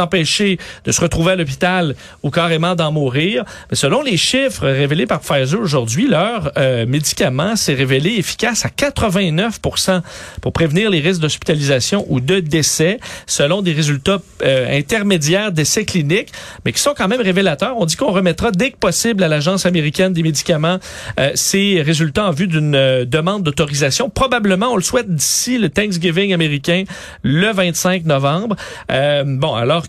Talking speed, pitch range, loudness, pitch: 165 wpm, 150-195 Hz, -15 LUFS, 175 Hz